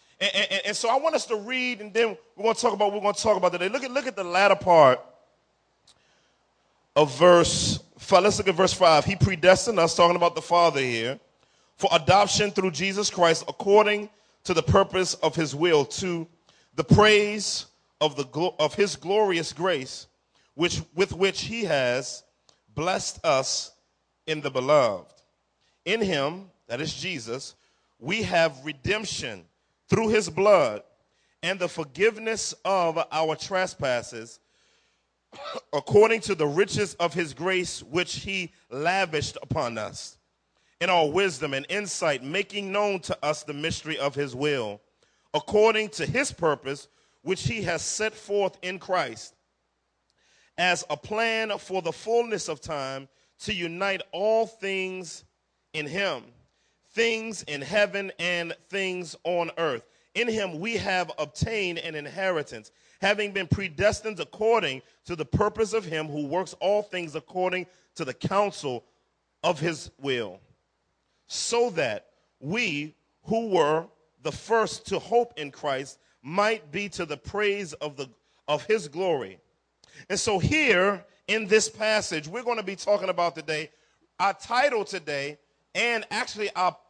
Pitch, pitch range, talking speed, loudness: 185 Hz, 155-210 Hz, 150 wpm, -25 LUFS